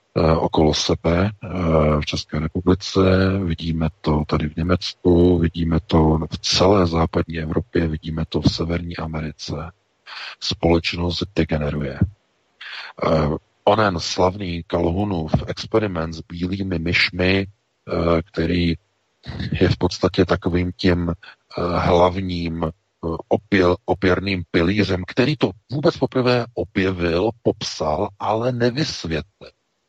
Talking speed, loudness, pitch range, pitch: 95 wpm, -20 LUFS, 80-95 Hz, 90 Hz